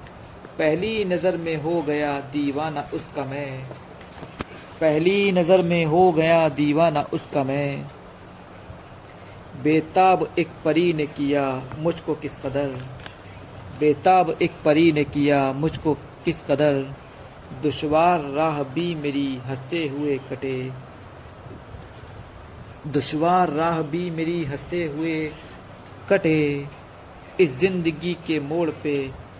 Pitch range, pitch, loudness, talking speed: 140-165 Hz, 150 Hz, -22 LUFS, 105 wpm